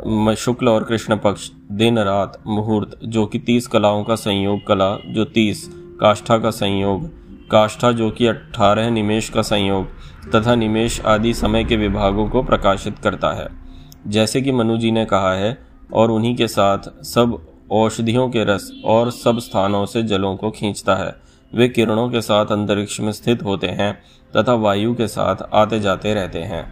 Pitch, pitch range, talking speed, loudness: 110 Hz, 100-115 Hz, 160 wpm, -18 LUFS